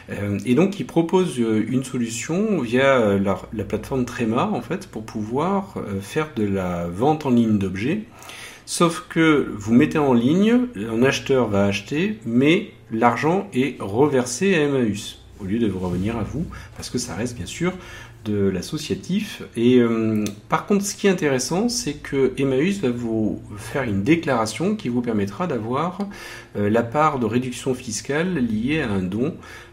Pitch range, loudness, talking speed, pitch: 110-155 Hz, -22 LUFS, 170 wpm, 125 Hz